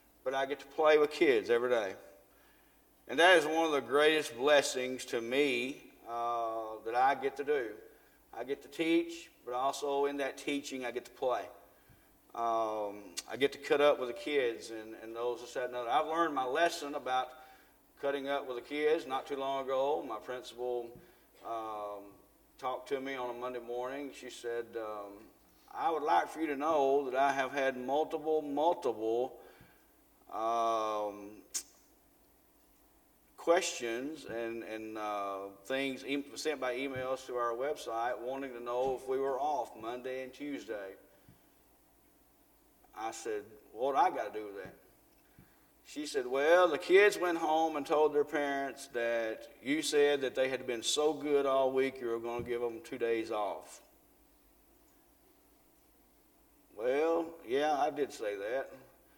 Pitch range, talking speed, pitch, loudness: 120-170 Hz, 165 wpm, 140 Hz, -33 LUFS